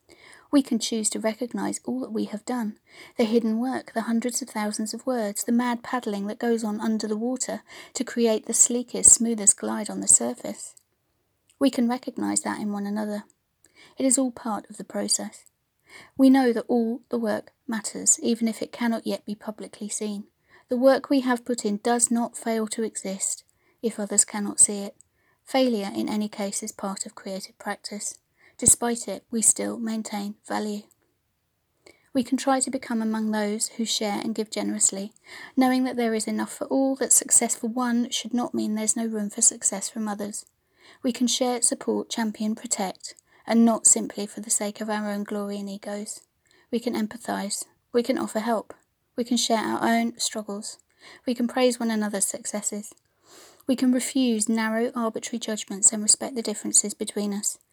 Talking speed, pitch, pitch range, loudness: 185 wpm, 225 Hz, 210-245 Hz, -24 LUFS